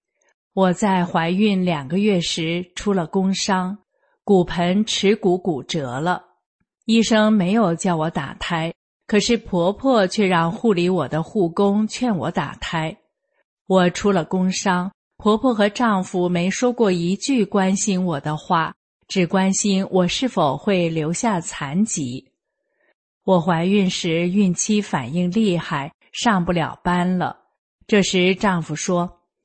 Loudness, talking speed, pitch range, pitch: -20 LUFS, 190 characters per minute, 175-205 Hz, 185 Hz